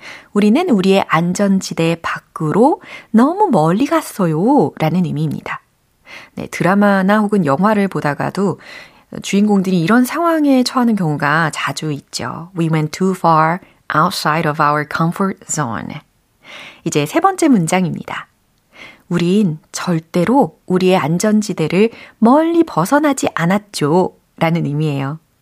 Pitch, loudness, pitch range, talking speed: 190 Hz, -15 LUFS, 160-230 Hz, 315 characters per minute